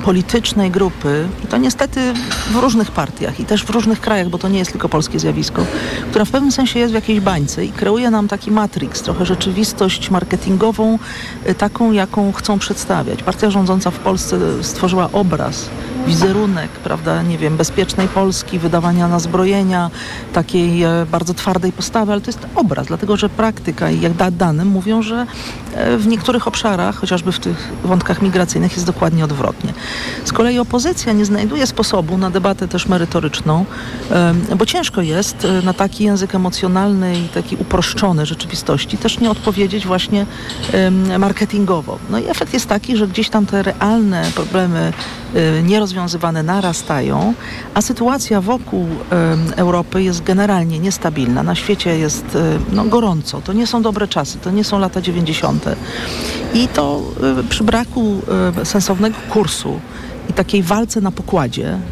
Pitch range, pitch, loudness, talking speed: 175-215 Hz, 190 Hz, -16 LUFS, 150 wpm